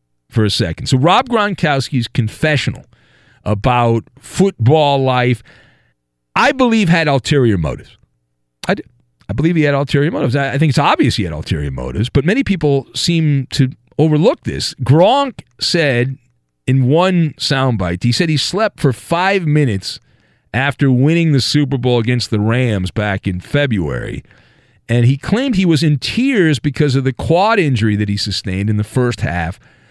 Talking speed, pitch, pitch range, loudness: 160 wpm, 135 Hz, 110-155 Hz, -15 LUFS